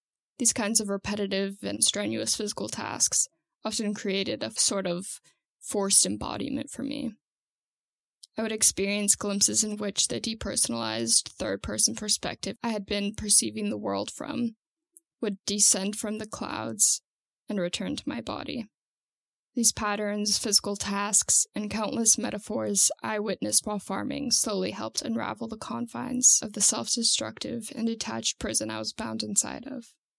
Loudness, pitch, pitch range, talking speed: -26 LUFS, 210 Hz, 195-230 Hz, 145 wpm